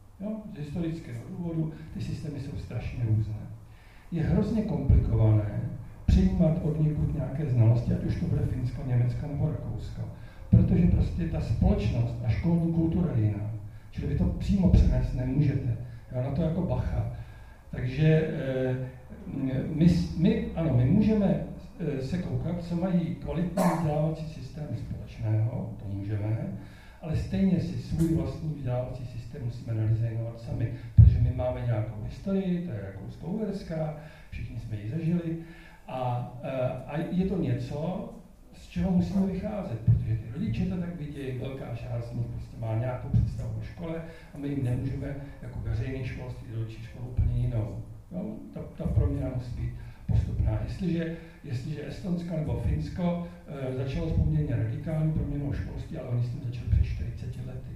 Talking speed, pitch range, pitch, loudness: 150 wpm, 115-160 Hz, 130 Hz, -29 LUFS